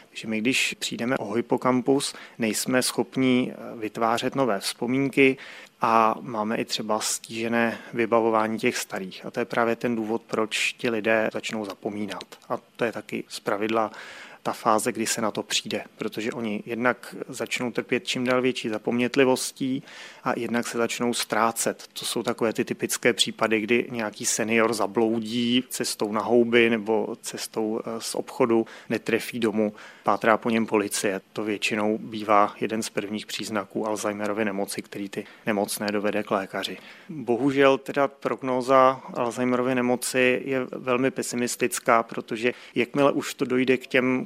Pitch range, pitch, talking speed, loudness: 110-125 Hz, 115 Hz, 150 wpm, -25 LUFS